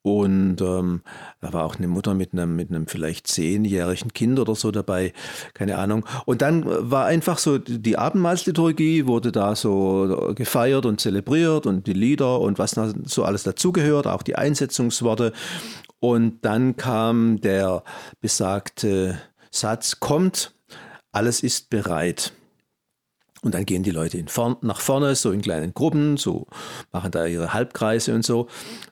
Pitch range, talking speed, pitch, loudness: 95-130 Hz, 150 wpm, 110 Hz, -22 LUFS